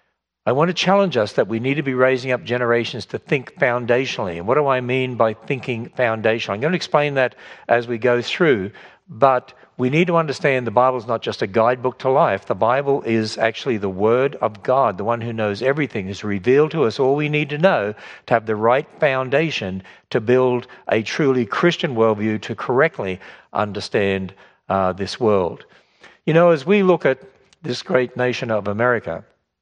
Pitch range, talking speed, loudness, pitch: 110-140 Hz, 195 wpm, -19 LUFS, 125 Hz